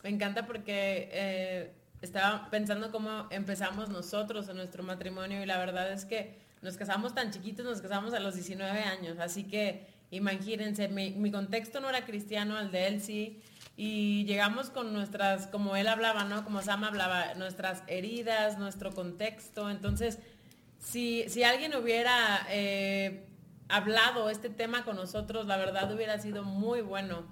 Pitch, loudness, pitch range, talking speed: 205 Hz, -33 LUFS, 195-220 Hz, 160 wpm